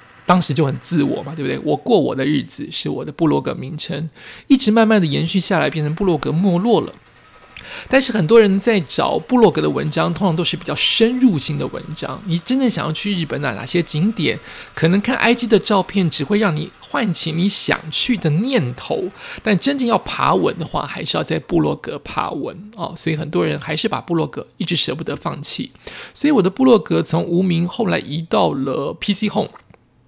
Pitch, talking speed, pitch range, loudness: 185 Hz, 315 characters per minute, 160-220 Hz, -18 LUFS